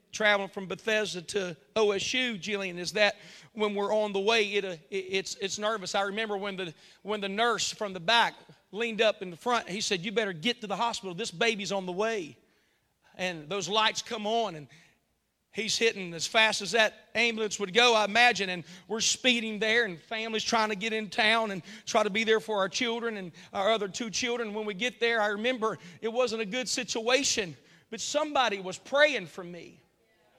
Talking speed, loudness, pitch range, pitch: 205 wpm, -28 LUFS, 195-230 Hz, 215 Hz